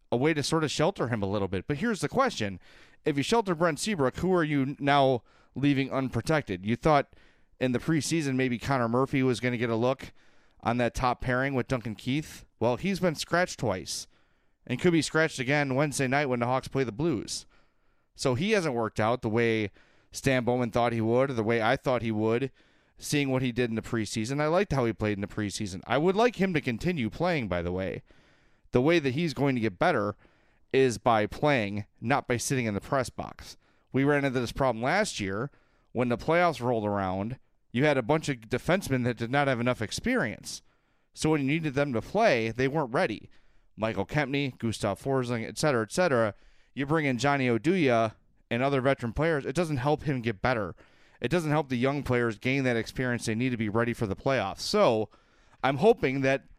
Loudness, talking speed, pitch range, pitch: -28 LUFS, 215 wpm, 115-145 Hz, 130 Hz